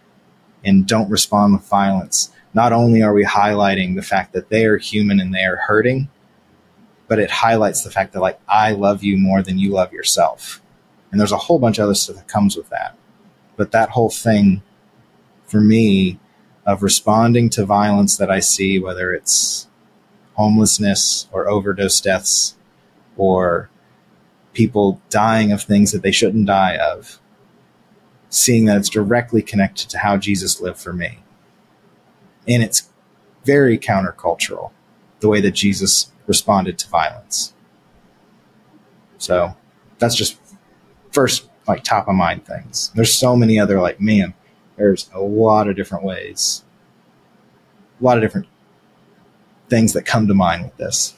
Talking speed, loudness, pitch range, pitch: 150 wpm, -16 LUFS, 100-110 Hz, 105 Hz